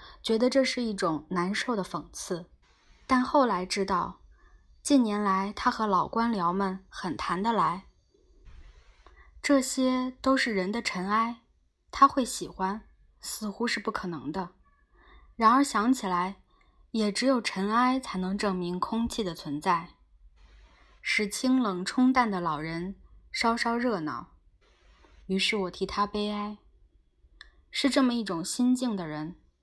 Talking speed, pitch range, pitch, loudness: 190 characters per minute, 185-250 Hz, 210 Hz, -28 LUFS